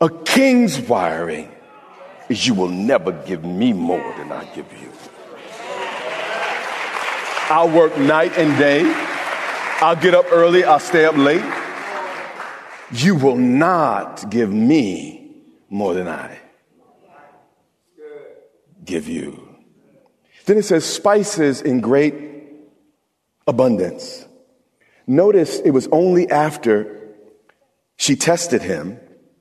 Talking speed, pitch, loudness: 105 wpm, 170 Hz, -17 LUFS